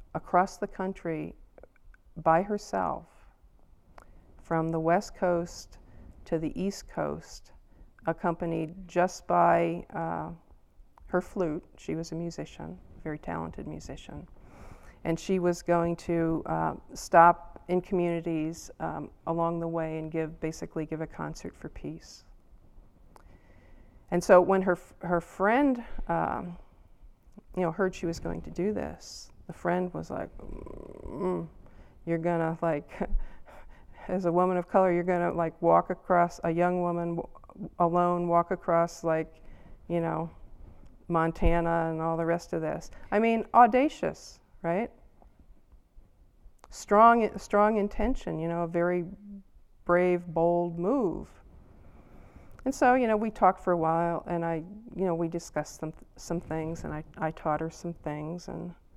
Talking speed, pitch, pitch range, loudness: 140 wpm, 170 Hz, 160-180 Hz, -29 LUFS